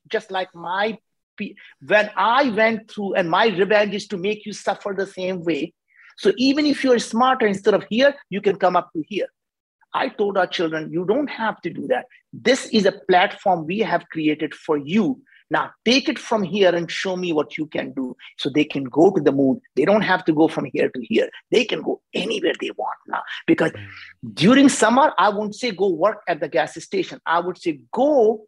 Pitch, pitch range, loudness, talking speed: 205 Hz, 175-230 Hz, -20 LUFS, 215 wpm